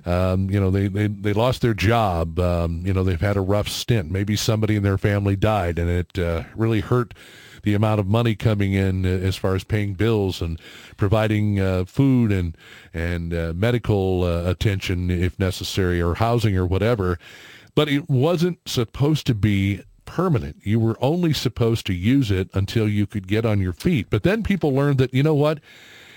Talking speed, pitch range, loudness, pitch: 195 wpm, 95-115 Hz, -21 LUFS, 105 Hz